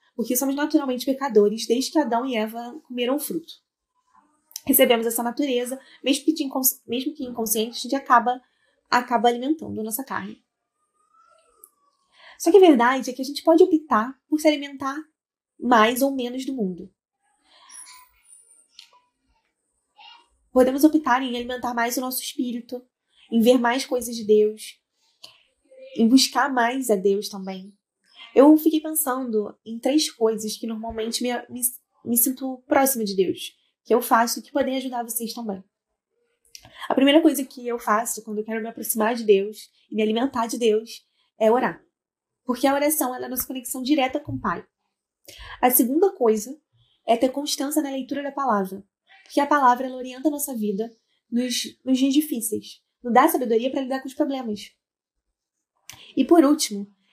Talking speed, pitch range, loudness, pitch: 160 wpm, 230-295 Hz, -22 LUFS, 255 Hz